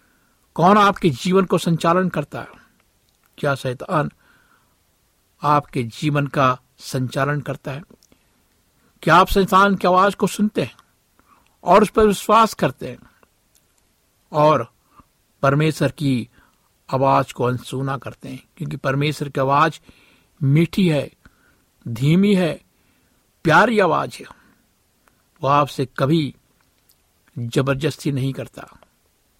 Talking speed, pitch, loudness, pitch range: 110 wpm, 145 Hz, -19 LUFS, 130-175 Hz